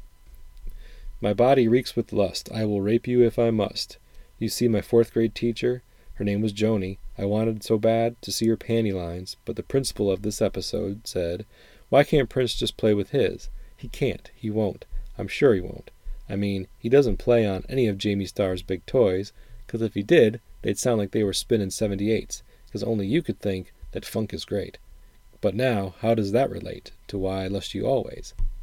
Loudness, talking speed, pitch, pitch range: -25 LUFS, 205 wpm, 110 Hz, 100-115 Hz